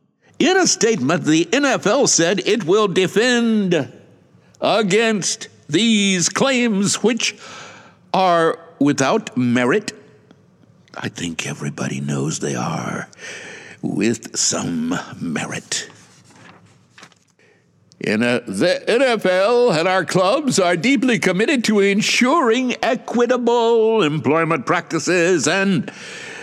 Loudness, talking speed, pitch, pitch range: -17 LUFS, 95 wpm, 205 Hz, 170-240 Hz